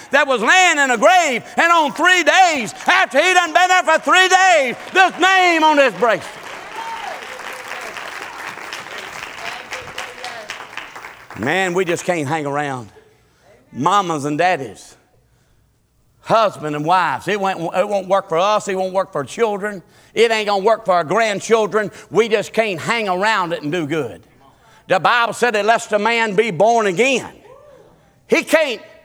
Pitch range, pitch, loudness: 190-315 Hz, 225 Hz, -16 LUFS